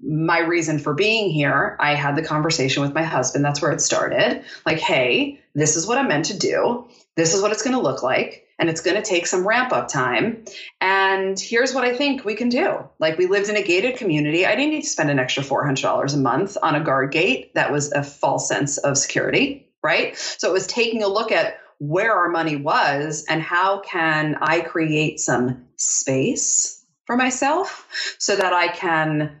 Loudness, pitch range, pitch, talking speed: -20 LUFS, 155-220 Hz, 175 Hz, 210 wpm